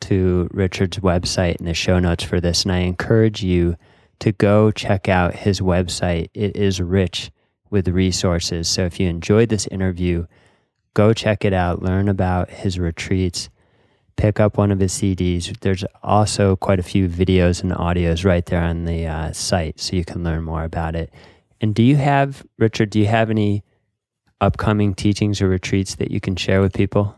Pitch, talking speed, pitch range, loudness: 95 Hz, 185 wpm, 90-105 Hz, -19 LUFS